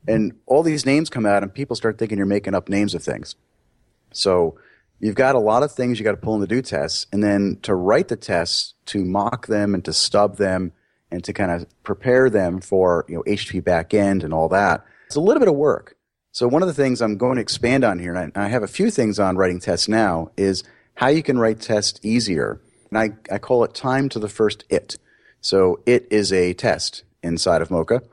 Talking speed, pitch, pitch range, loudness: 235 wpm, 105 Hz, 95-120 Hz, -20 LUFS